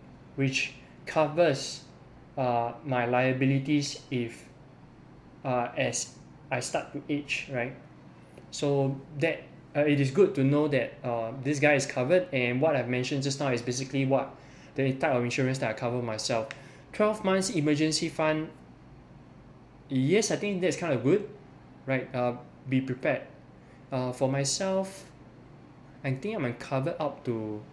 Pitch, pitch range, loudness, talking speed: 135 Hz, 125-150 Hz, -29 LUFS, 150 wpm